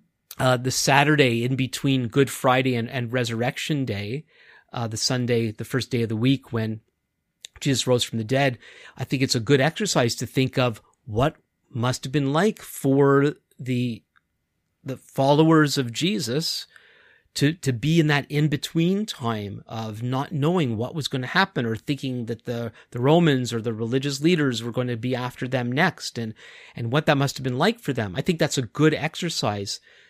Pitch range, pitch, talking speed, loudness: 120-145 Hz, 130 Hz, 185 wpm, -23 LUFS